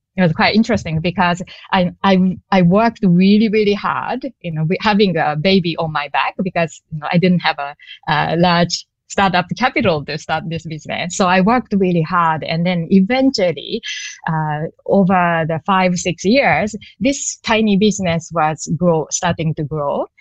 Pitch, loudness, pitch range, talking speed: 180 Hz, -16 LUFS, 165-205 Hz, 170 wpm